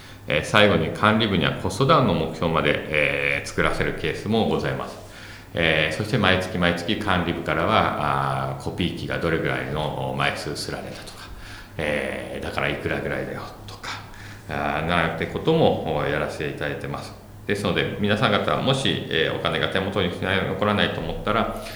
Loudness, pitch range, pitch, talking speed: -23 LUFS, 75-105 Hz, 85 Hz, 345 characters per minute